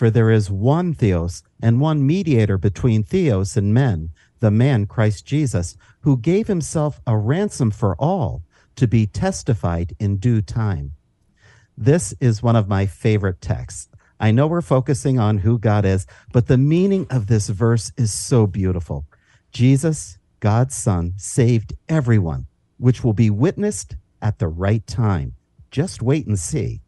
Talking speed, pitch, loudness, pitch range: 155 wpm, 110 Hz, -19 LUFS, 100-130 Hz